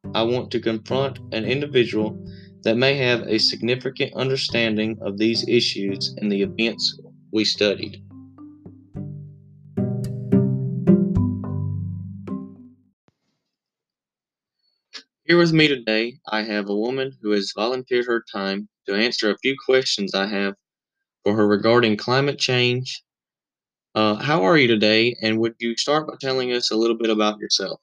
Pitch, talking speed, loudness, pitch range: 115 Hz, 135 wpm, -21 LUFS, 105-130 Hz